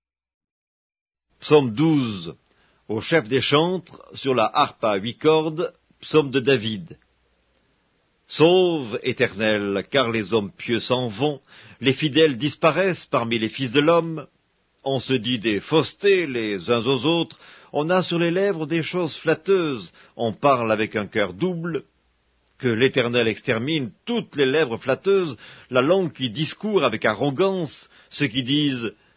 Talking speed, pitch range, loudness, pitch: 145 wpm, 115-160 Hz, -22 LUFS, 135 Hz